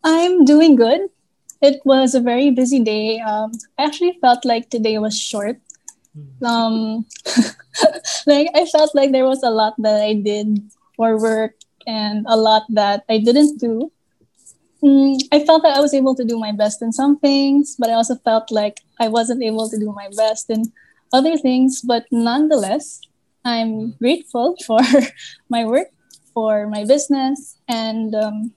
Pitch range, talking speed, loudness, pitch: 220-280 Hz, 165 wpm, -16 LUFS, 240 Hz